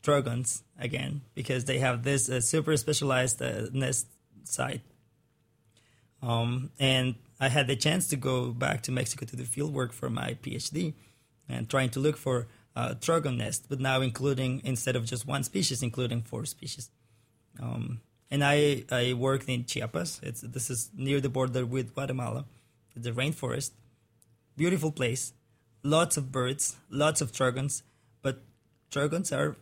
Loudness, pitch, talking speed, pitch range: -30 LUFS, 130 Hz, 155 wpm, 120-140 Hz